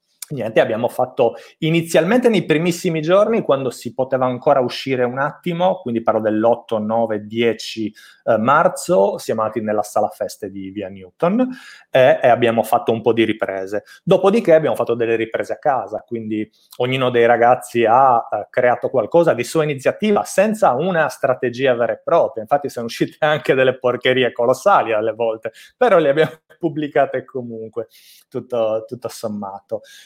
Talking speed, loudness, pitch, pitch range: 150 wpm, -18 LUFS, 125 Hz, 115-160 Hz